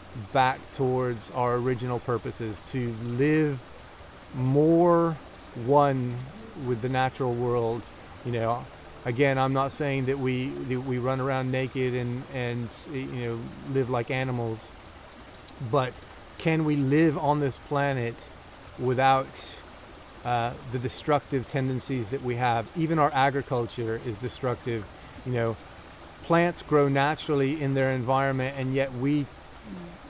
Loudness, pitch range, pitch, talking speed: -27 LUFS, 120-135 Hz, 130 Hz, 130 wpm